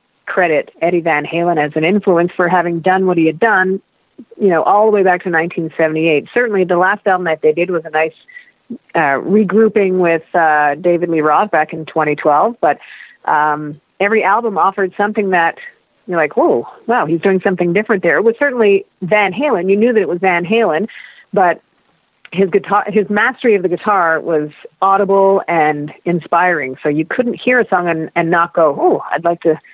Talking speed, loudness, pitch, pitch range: 200 wpm, -14 LUFS, 180 Hz, 160-205 Hz